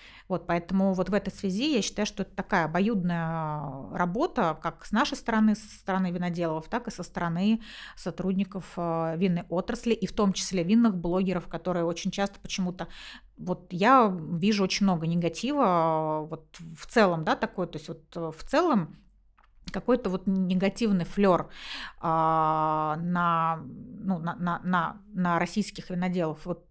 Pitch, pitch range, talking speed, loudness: 180 Hz, 170-205 Hz, 150 wpm, -28 LUFS